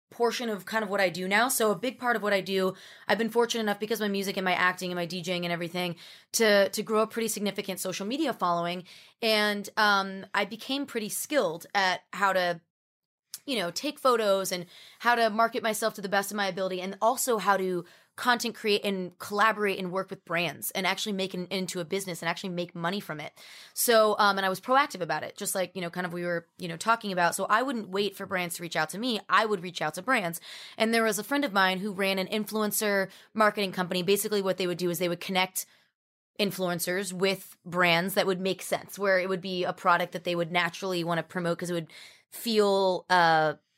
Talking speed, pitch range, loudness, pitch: 240 wpm, 180-215 Hz, -28 LUFS, 195 Hz